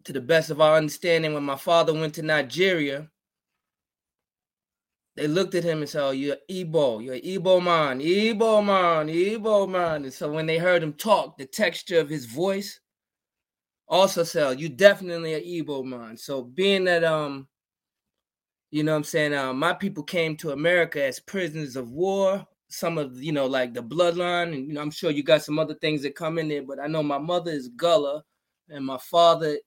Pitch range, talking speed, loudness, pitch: 145-175 Hz, 195 wpm, -24 LUFS, 160 Hz